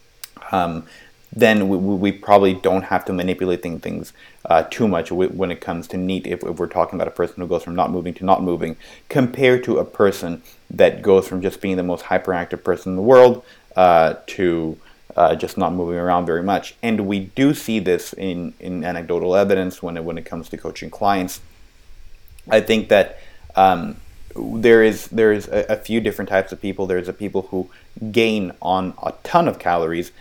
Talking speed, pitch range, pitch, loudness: 195 wpm, 90-105 Hz, 95 Hz, -19 LUFS